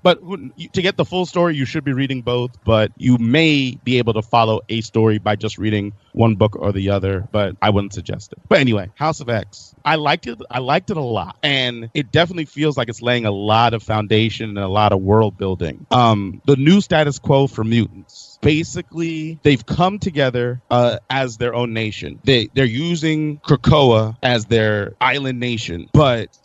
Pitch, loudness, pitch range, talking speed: 120 Hz, -18 LUFS, 110-145 Hz, 200 wpm